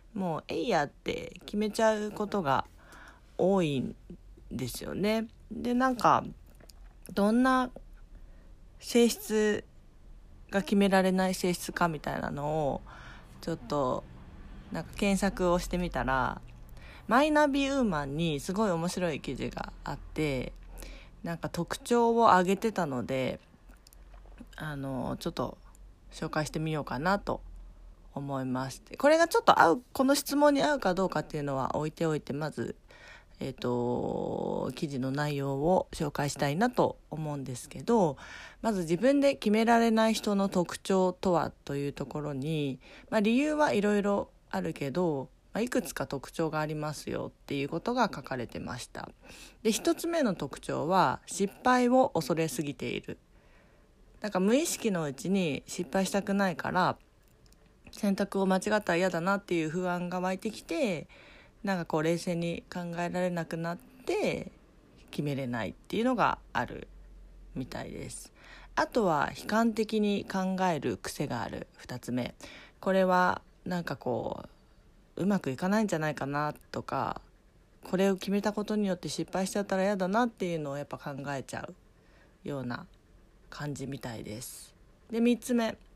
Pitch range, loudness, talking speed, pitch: 145-210 Hz, -30 LUFS, 300 characters per minute, 180 Hz